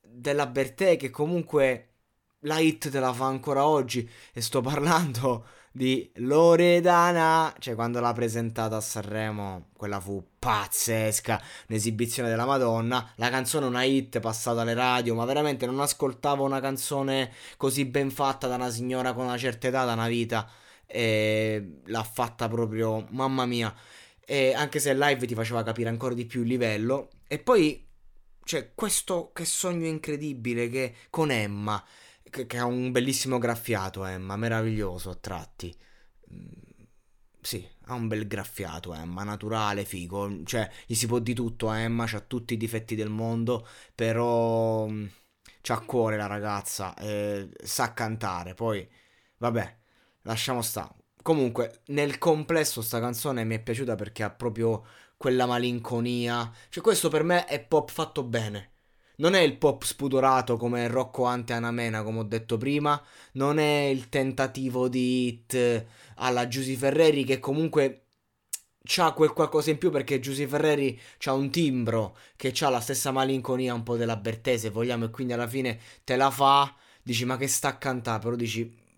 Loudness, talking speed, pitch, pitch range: -27 LUFS, 160 wpm, 120 Hz, 115-135 Hz